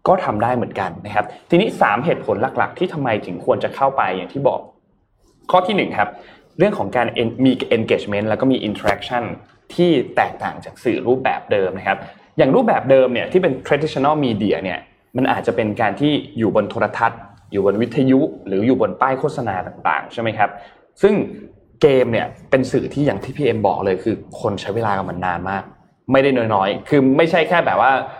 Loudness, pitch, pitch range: -18 LUFS, 120 Hz, 100-140 Hz